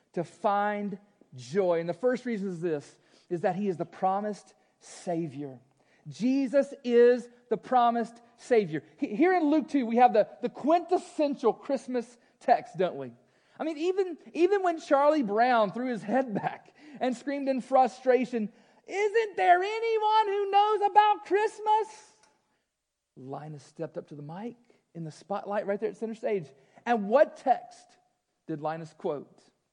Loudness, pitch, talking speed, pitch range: -28 LUFS, 240 Hz, 155 wpm, 200-310 Hz